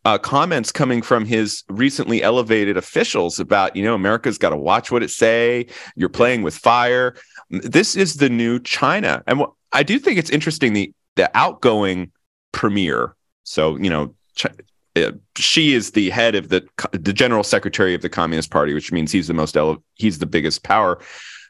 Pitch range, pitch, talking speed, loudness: 90-125 Hz, 105 Hz, 185 wpm, -18 LUFS